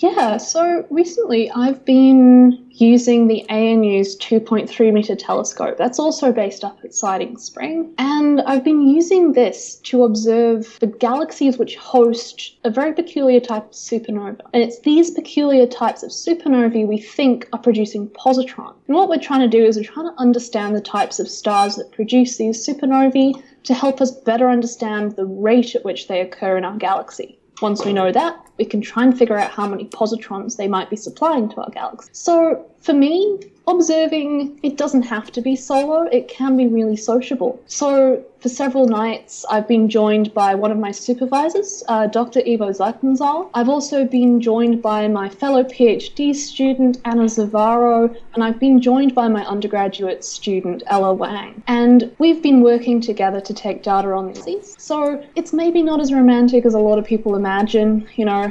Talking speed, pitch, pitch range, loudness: 185 wpm, 240 Hz, 215-275 Hz, -17 LUFS